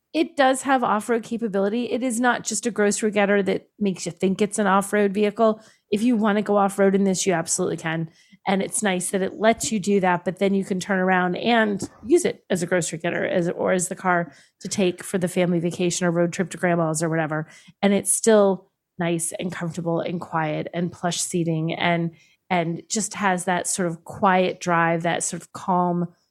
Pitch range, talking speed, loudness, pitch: 175-205 Hz, 215 wpm, -22 LUFS, 190 Hz